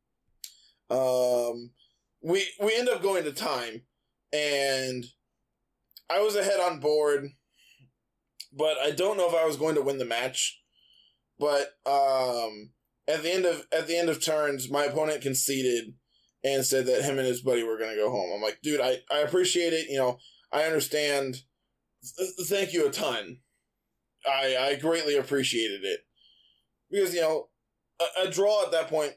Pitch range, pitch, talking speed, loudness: 130-170 Hz, 145 Hz, 170 wpm, -27 LUFS